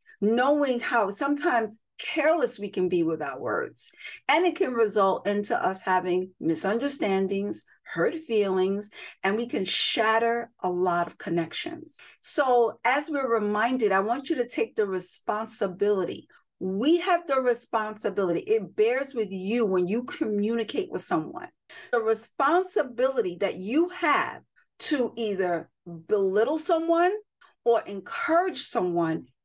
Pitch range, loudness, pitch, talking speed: 195-315 Hz, -26 LUFS, 230 Hz, 130 wpm